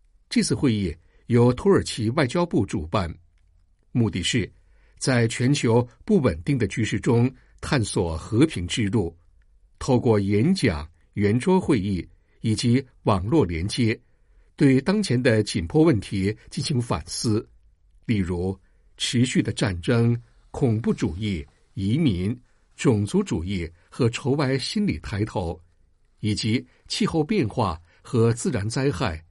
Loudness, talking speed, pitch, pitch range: -24 LUFS, 190 characters per minute, 110 Hz, 90-125 Hz